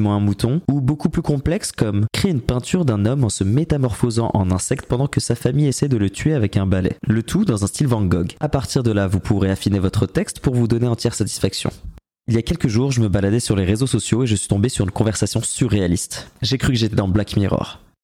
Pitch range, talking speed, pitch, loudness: 100-135 Hz, 255 wpm, 115 Hz, -19 LUFS